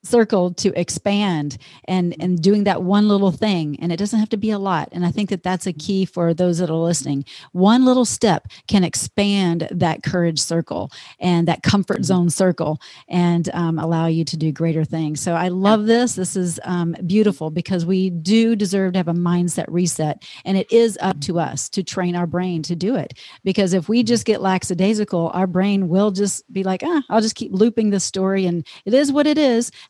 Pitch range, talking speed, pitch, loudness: 170-205 Hz, 215 wpm, 185 Hz, -19 LUFS